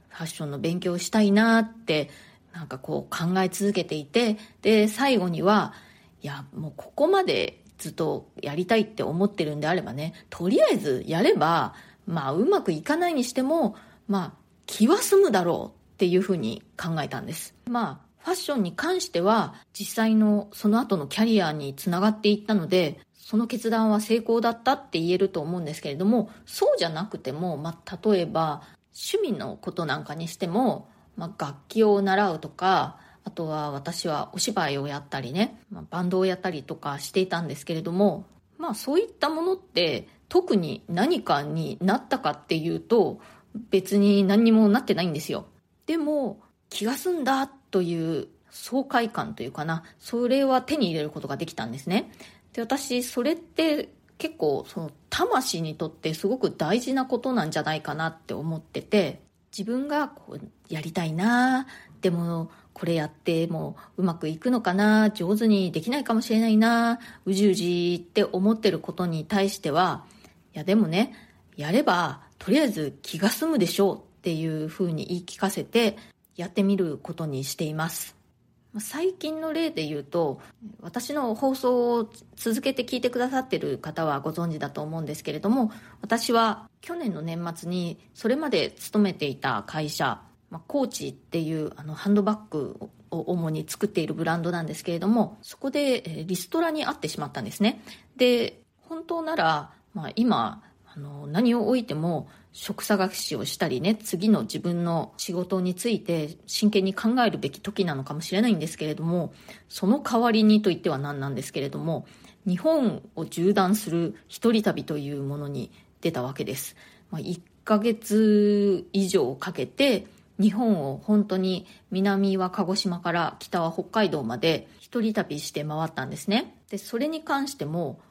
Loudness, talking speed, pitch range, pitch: -26 LUFS, 330 characters per minute, 165-230 Hz, 195 Hz